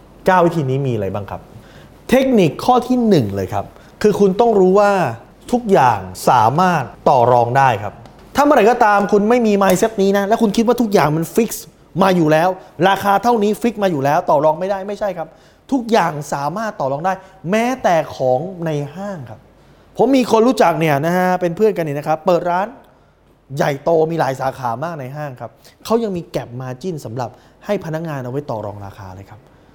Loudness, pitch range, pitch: -16 LUFS, 135-205 Hz, 170 Hz